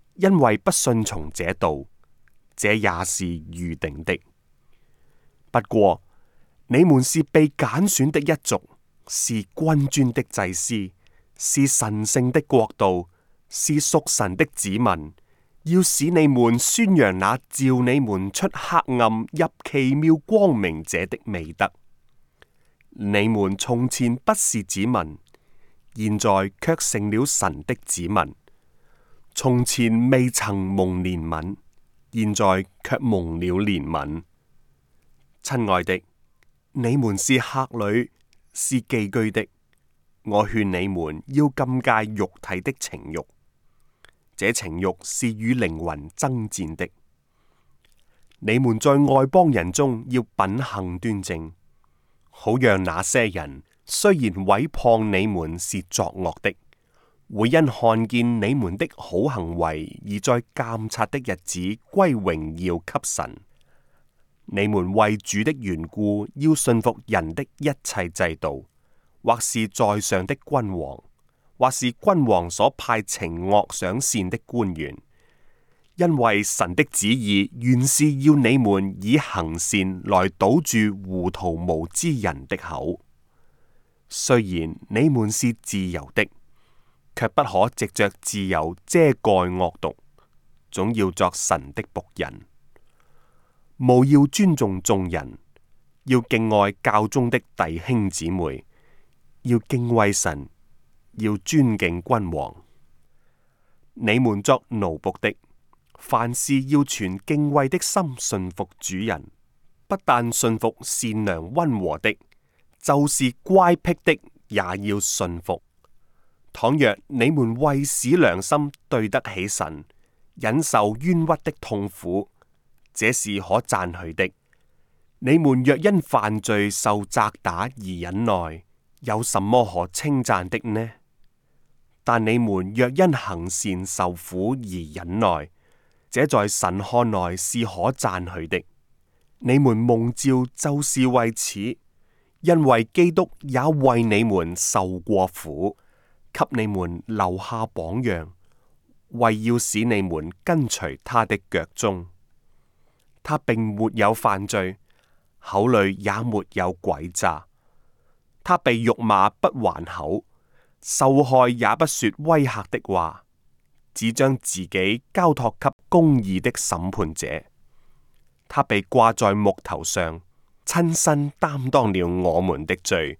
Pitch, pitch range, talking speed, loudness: 105 Hz, 90-130 Hz, 170 characters per minute, -22 LUFS